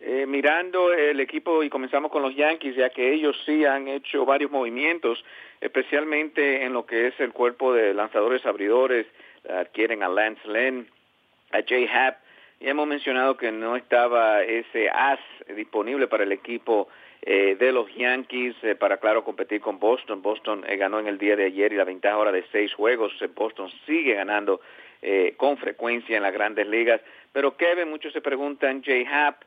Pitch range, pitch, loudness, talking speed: 115-150 Hz, 130 Hz, -24 LUFS, 180 wpm